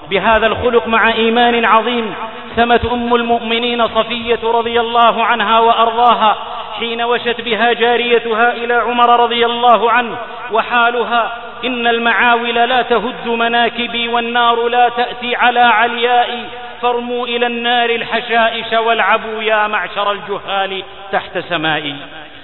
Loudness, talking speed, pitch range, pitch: -13 LUFS, 115 wpm, 225-240 Hz, 235 Hz